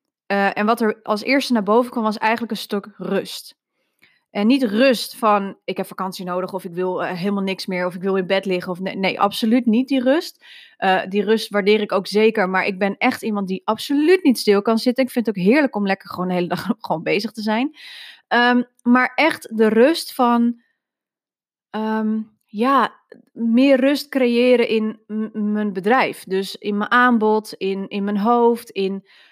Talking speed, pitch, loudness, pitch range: 205 wpm, 220 Hz, -19 LUFS, 195-245 Hz